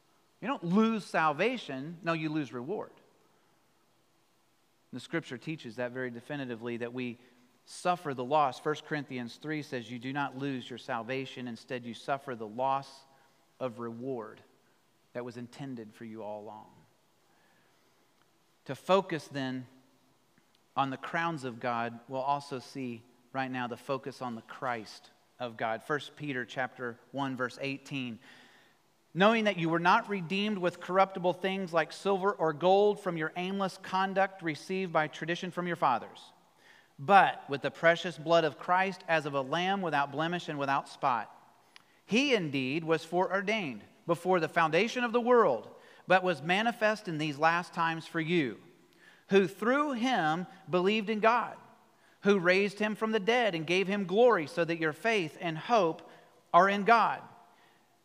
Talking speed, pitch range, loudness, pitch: 160 wpm, 130-190 Hz, -31 LUFS, 160 Hz